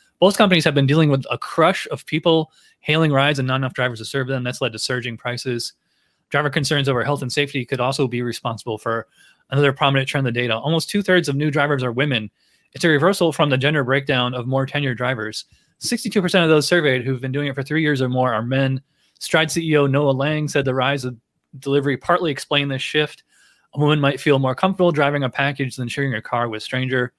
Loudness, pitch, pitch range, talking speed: -19 LUFS, 140 Hz, 130-150 Hz, 230 wpm